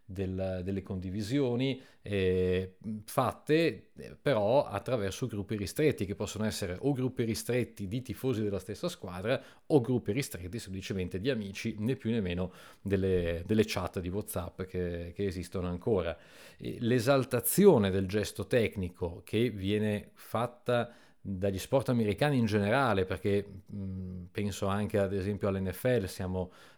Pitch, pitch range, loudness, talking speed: 100 Hz, 95-120 Hz, -32 LUFS, 135 wpm